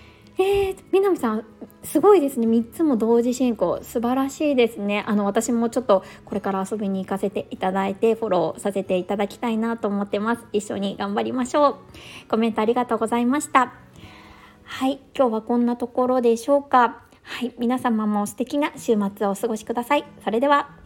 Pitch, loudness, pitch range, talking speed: 235 Hz, -22 LUFS, 205-255 Hz, 385 characters per minute